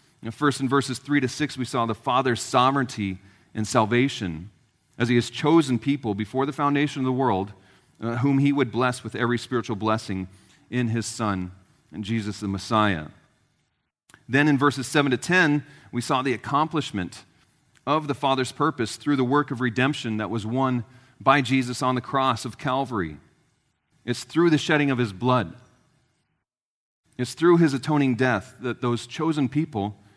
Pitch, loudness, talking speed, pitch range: 125 Hz, -24 LUFS, 170 wpm, 110-140 Hz